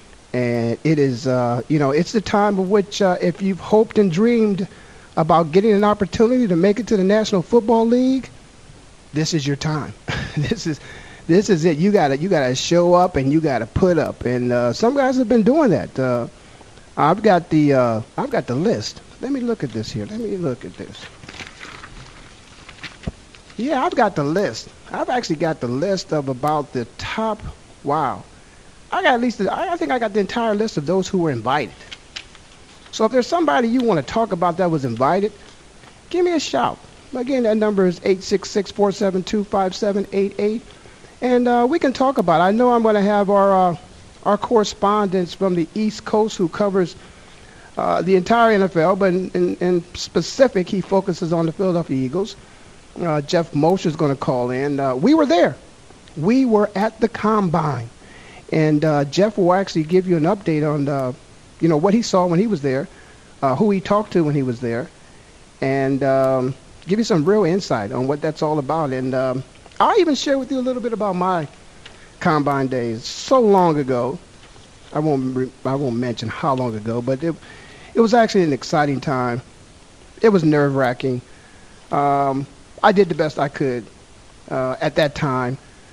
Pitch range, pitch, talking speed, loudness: 140-210 Hz, 180 Hz, 190 wpm, -19 LUFS